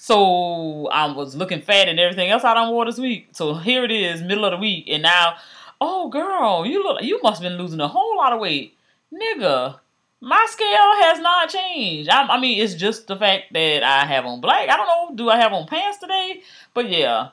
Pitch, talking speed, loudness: 220 Hz, 230 wpm, -18 LUFS